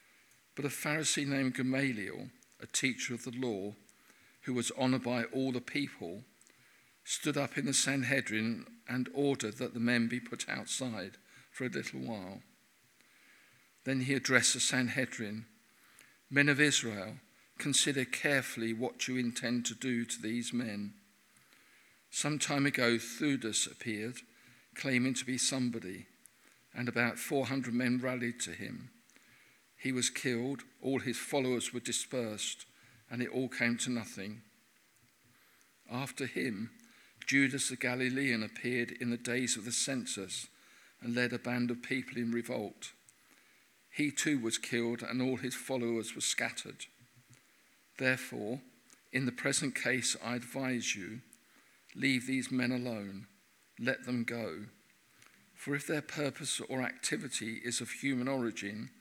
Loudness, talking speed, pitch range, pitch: -34 LUFS, 140 wpm, 120-130 Hz, 125 Hz